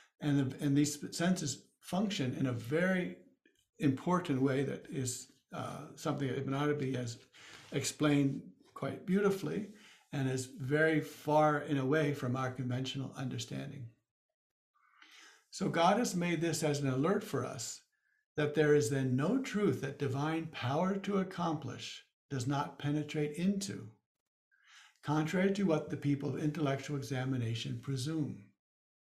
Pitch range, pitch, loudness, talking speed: 135-160 Hz, 145 Hz, -35 LUFS, 140 wpm